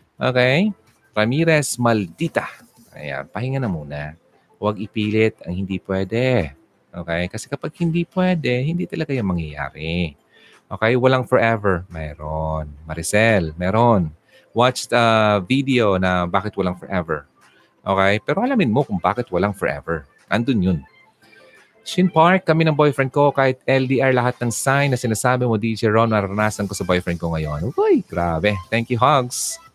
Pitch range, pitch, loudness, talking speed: 90-130 Hz, 110 Hz, -20 LUFS, 145 wpm